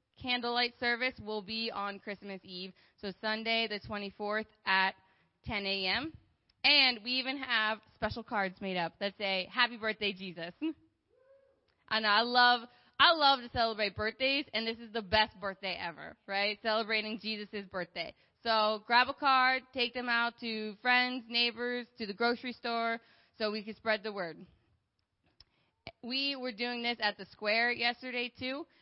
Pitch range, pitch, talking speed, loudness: 205-245 Hz, 225 Hz, 160 wpm, -32 LUFS